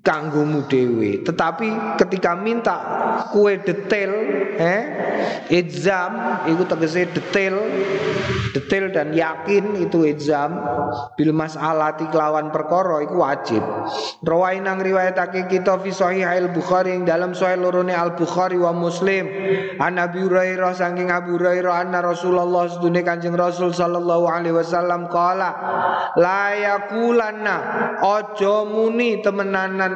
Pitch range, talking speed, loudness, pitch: 170-195 Hz, 110 wpm, -20 LUFS, 180 Hz